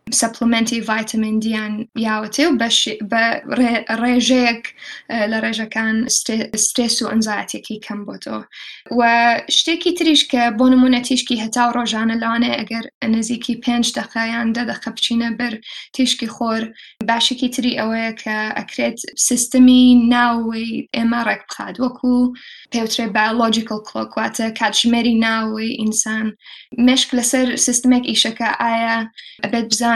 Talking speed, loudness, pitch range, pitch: 105 wpm, -17 LUFS, 225-245 Hz, 230 Hz